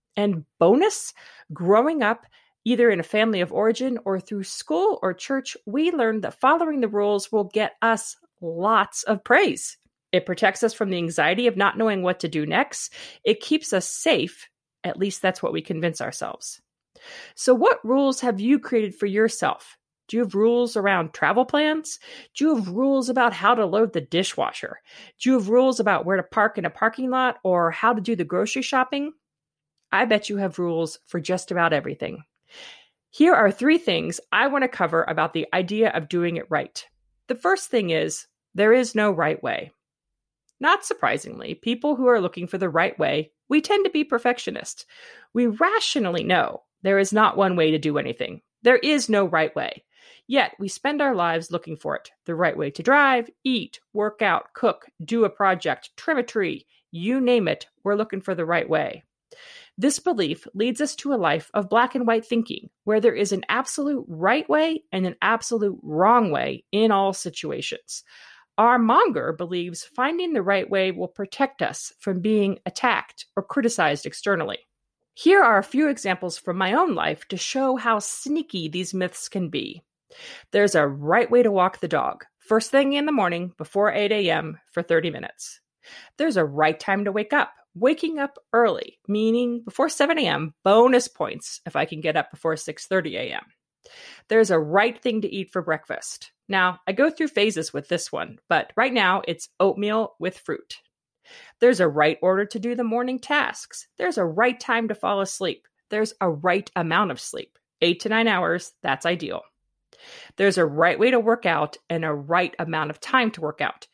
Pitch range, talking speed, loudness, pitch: 180-260 Hz, 190 wpm, -22 LUFS, 215 Hz